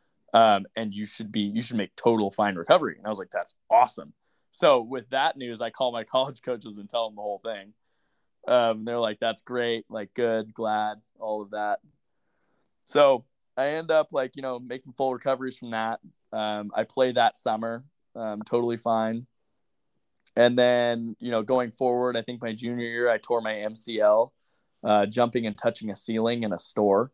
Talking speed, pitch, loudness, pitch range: 190 wpm, 115 Hz, -26 LUFS, 110-125 Hz